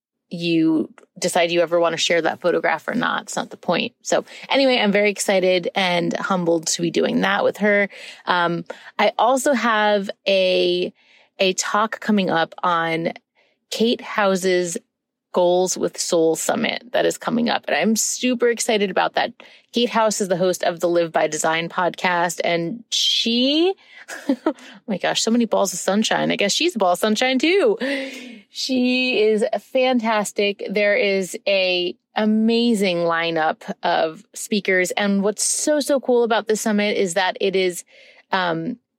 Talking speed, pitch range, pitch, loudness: 165 wpm, 180-235 Hz, 205 Hz, -20 LUFS